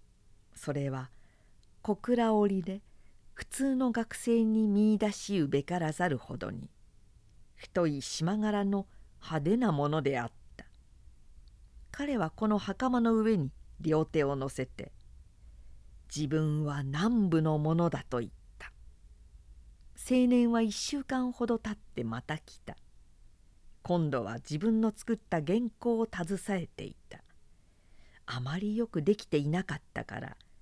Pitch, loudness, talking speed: 160 Hz, -31 LUFS, 225 characters per minute